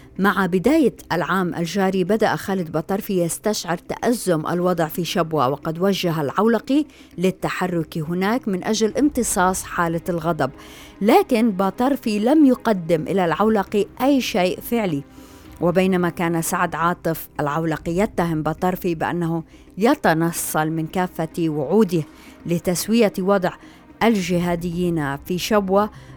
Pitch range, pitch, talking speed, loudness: 165-210 Hz, 180 Hz, 110 wpm, -21 LUFS